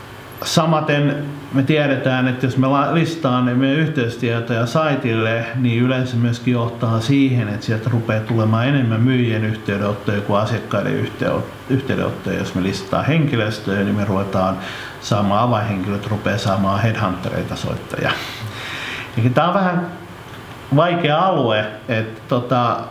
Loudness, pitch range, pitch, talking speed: -19 LUFS, 105-135 Hz, 120 Hz, 120 wpm